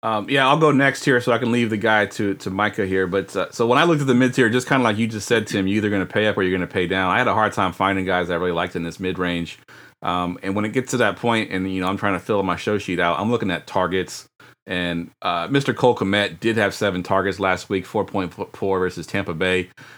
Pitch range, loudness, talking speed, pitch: 90-115 Hz, -21 LUFS, 305 wpm, 100 Hz